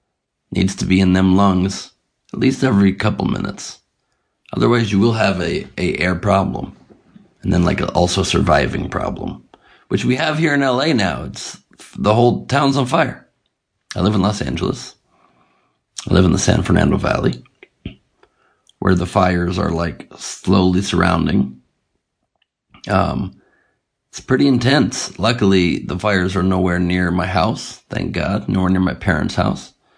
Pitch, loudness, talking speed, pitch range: 95 Hz, -17 LUFS, 155 wpm, 90-115 Hz